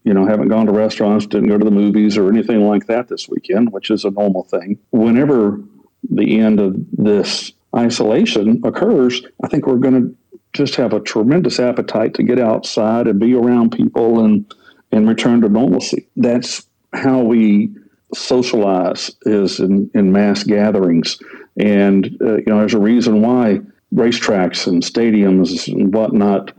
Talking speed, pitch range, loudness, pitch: 165 wpm, 105-120 Hz, -14 LUFS, 110 Hz